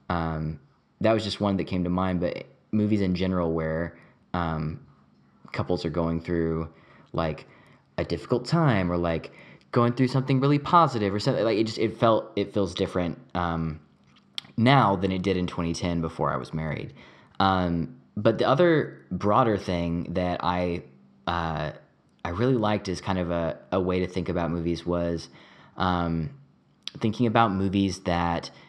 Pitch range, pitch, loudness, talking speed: 85-105 Hz, 90 Hz, -26 LUFS, 165 wpm